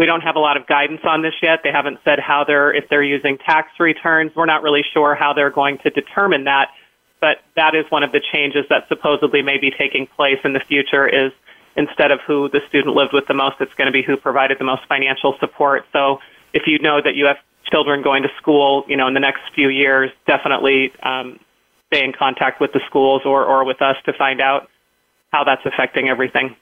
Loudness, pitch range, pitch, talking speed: -16 LUFS, 135-150 Hz, 140 Hz, 230 wpm